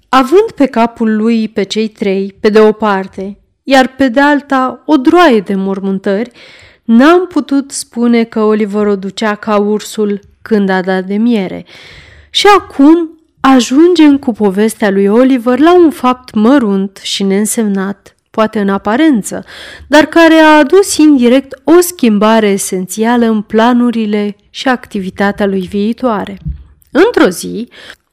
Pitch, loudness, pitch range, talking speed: 225 Hz, -10 LUFS, 205-275 Hz, 140 wpm